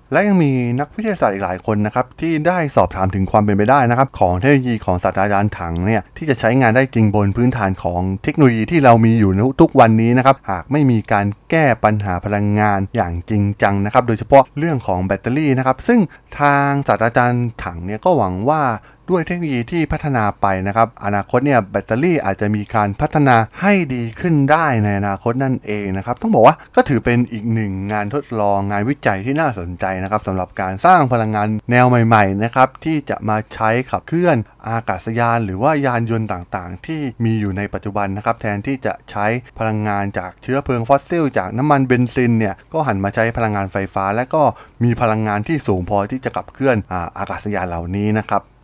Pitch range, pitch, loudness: 100-135 Hz, 115 Hz, -17 LUFS